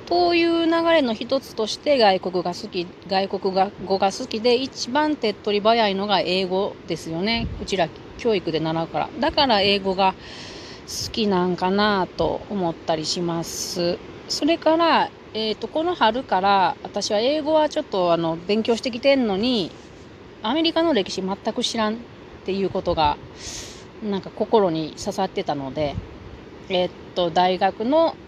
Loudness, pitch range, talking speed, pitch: -22 LUFS, 185-245 Hz, 295 characters per minute, 200 Hz